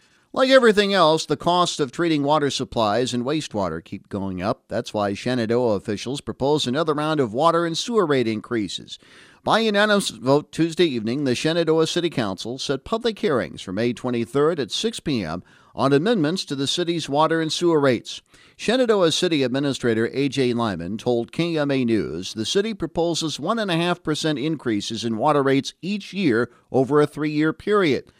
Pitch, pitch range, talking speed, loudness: 150 Hz, 120-170 Hz, 170 wpm, -22 LUFS